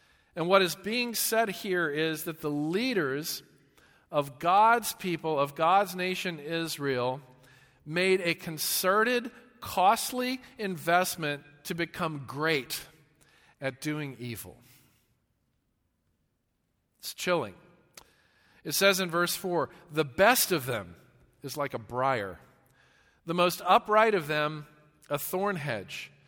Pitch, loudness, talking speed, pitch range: 160 Hz, -28 LUFS, 115 wpm, 140-185 Hz